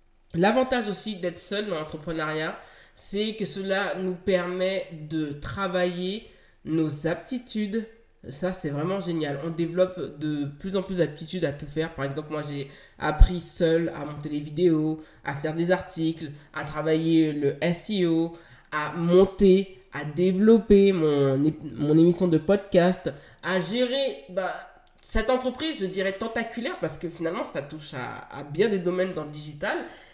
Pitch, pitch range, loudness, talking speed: 170 Hz, 155-195 Hz, -26 LUFS, 155 wpm